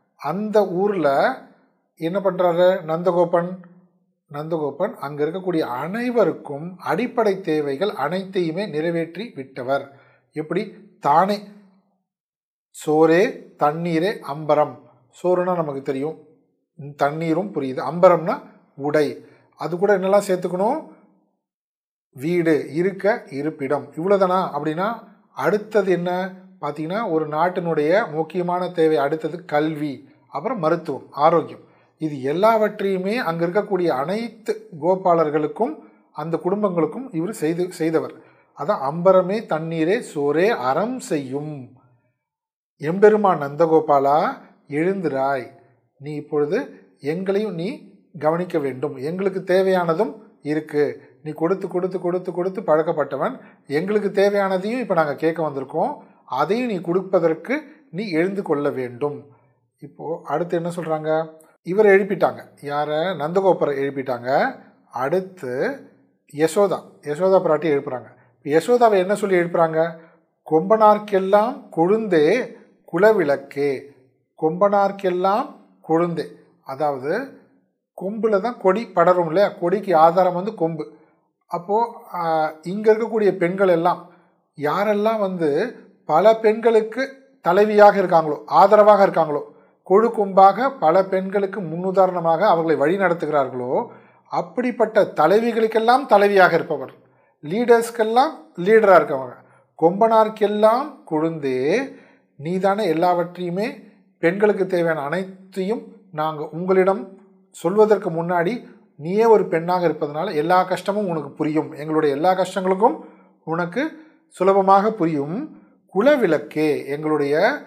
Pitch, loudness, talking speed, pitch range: 180 Hz, -20 LUFS, 95 wpm, 155-205 Hz